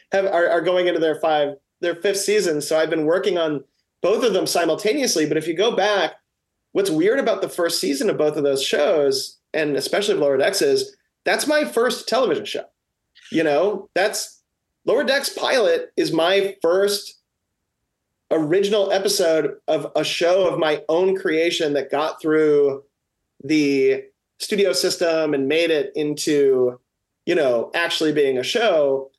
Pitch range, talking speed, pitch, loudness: 150-205 Hz, 165 wpm, 170 Hz, -20 LUFS